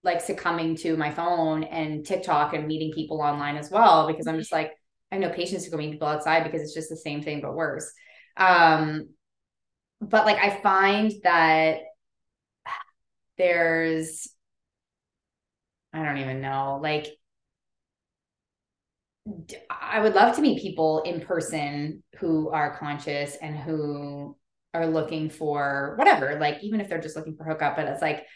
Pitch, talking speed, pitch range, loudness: 160 Hz, 155 wpm, 150-180 Hz, -24 LUFS